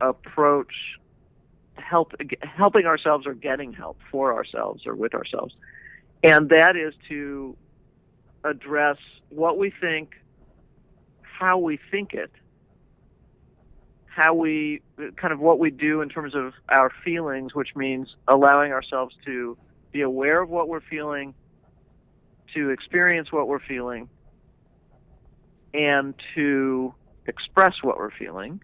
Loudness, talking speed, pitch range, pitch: -22 LUFS, 120 wpm, 135-160 Hz, 150 Hz